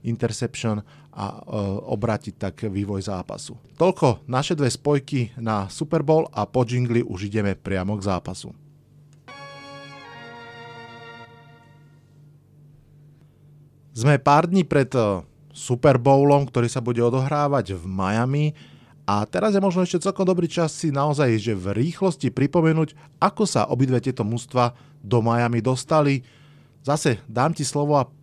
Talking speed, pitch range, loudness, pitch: 130 wpm, 115-145 Hz, -22 LUFS, 135 Hz